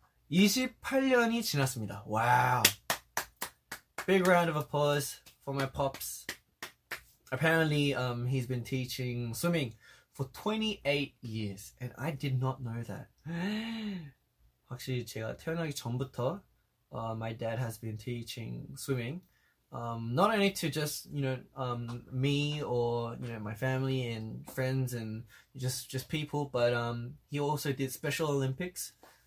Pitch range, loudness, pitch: 120-150 Hz, -33 LUFS, 130 Hz